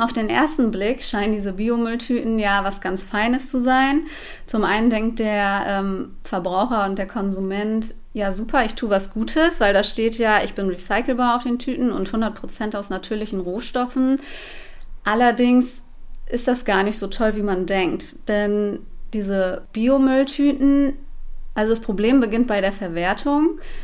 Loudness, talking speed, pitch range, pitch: -21 LUFS, 160 wpm, 200-250 Hz, 220 Hz